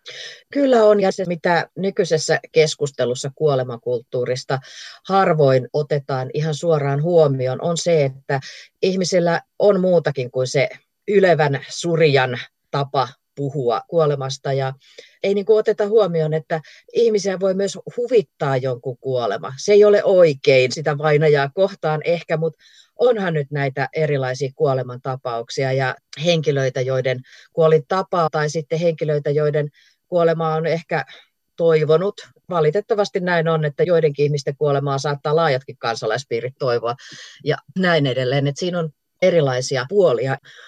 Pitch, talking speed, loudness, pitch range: 155 Hz, 125 wpm, -19 LUFS, 135-175 Hz